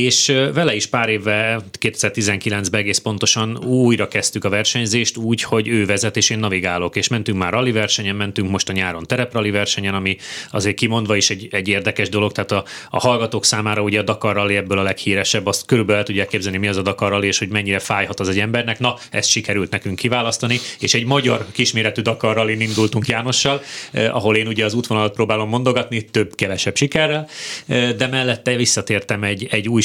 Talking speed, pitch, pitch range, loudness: 190 wpm, 110 Hz, 100-120 Hz, -18 LUFS